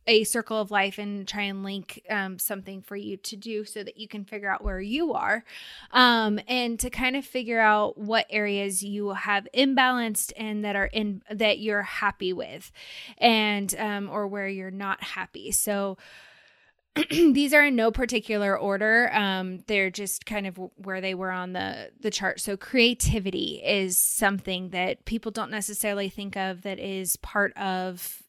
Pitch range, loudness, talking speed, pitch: 195-220 Hz, -25 LUFS, 175 wpm, 205 Hz